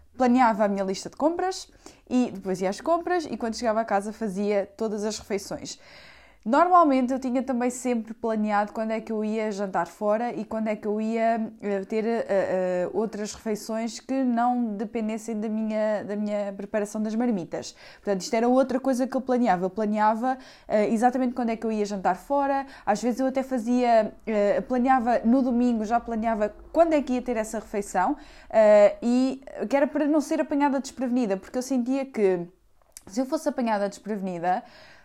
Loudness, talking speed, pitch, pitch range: -25 LUFS, 185 wpm, 225 Hz, 210-260 Hz